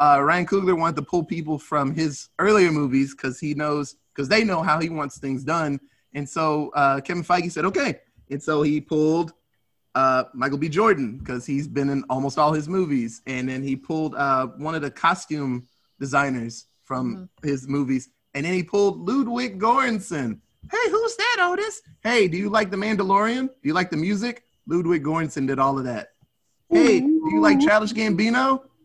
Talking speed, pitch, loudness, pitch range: 190 wpm, 155 Hz, -22 LUFS, 140-200 Hz